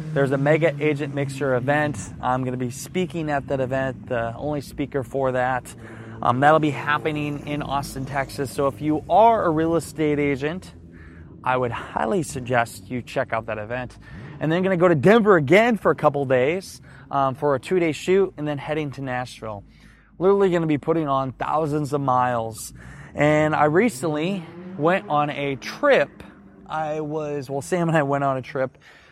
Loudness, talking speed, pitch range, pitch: -22 LUFS, 190 wpm, 125-155 Hz, 145 Hz